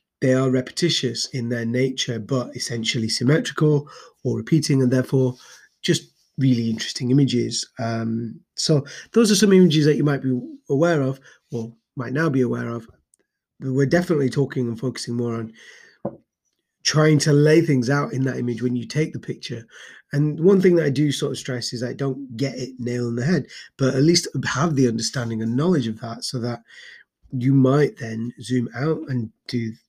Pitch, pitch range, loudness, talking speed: 130 Hz, 120-145 Hz, -21 LUFS, 185 wpm